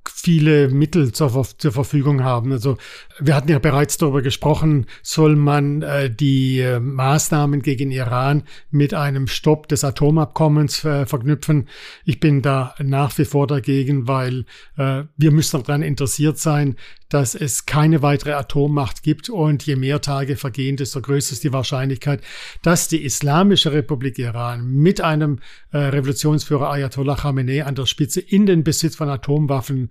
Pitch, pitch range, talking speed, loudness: 145 Hz, 135-150 Hz, 155 wpm, -18 LUFS